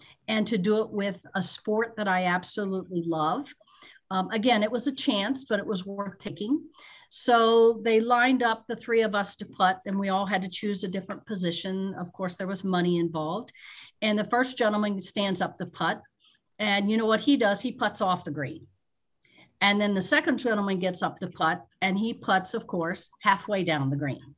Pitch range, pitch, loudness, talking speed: 185-225 Hz, 200 Hz, -27 LUFS, 205 wpm